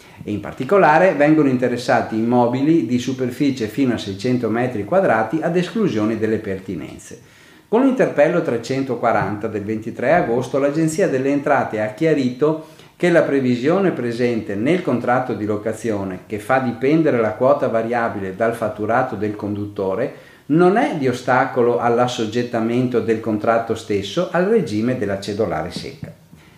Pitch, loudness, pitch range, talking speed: 120 Hz, -19 LUFS, 110-140 Hz, 135 wpm